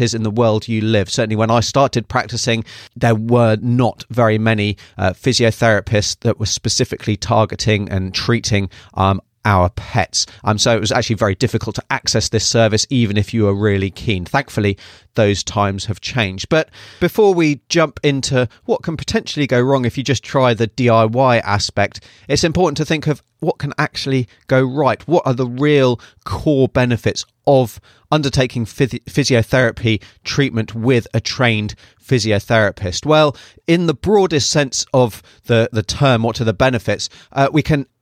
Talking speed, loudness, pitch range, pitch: 170 wpm, -16 LUFS, 105-130 Hz, 115 Hz